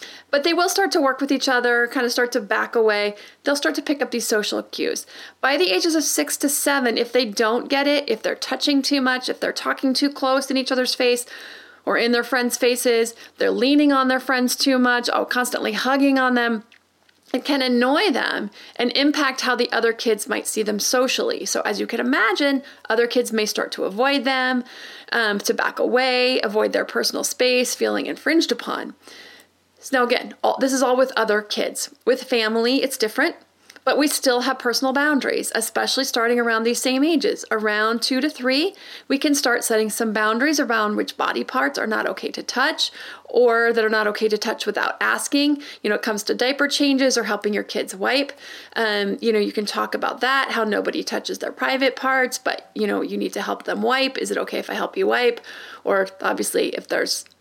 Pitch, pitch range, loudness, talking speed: 255 Hz, 235-280 Hz, -20 LUFS, 215 wpm